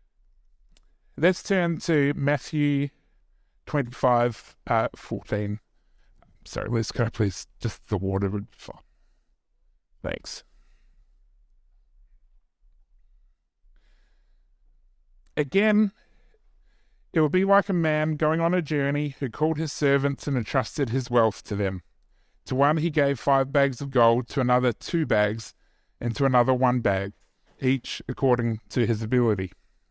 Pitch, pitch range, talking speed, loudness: 125 Hz, 105-145 Hz, 120 wpm, -25 LUFS